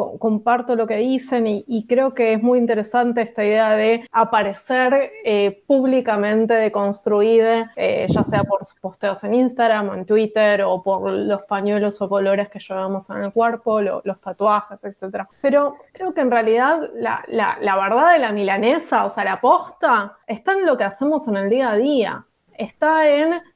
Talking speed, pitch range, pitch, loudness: 185 wpm, 200-250 Hz, 220 Hz, -19 LUFS